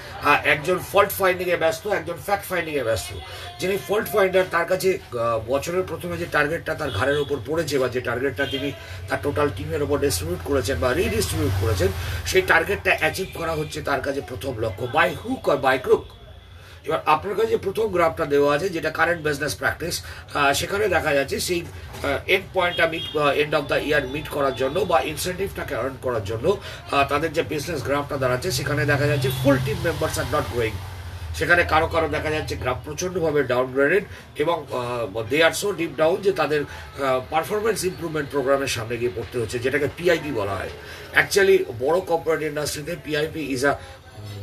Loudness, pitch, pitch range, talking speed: -23 LUFS, 145 Hz, 125-170 Hz, 170 wpm